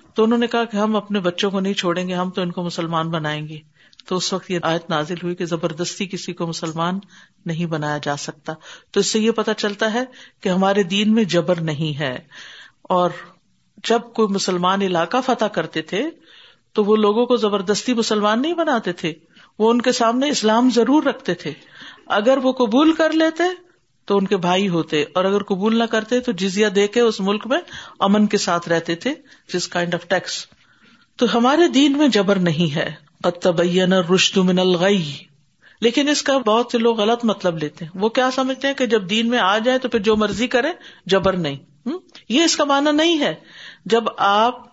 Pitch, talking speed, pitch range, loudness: 205 Hz, 200 wpm, 175-240 Hz, -19 LUFS